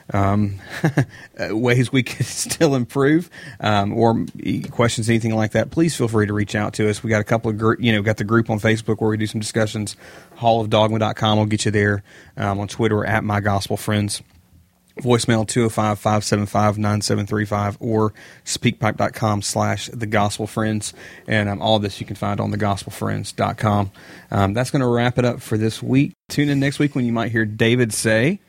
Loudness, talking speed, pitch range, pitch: -20 LUFS, 185 wpm, 105-120 Hz, 110 Hz